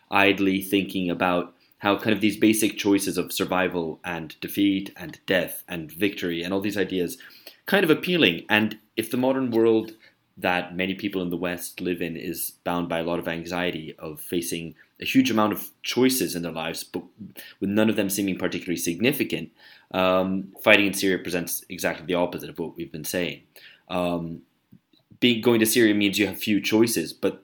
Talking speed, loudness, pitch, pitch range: 190 wpm, -24 LUFS, 95 Hz, 90-105 Hz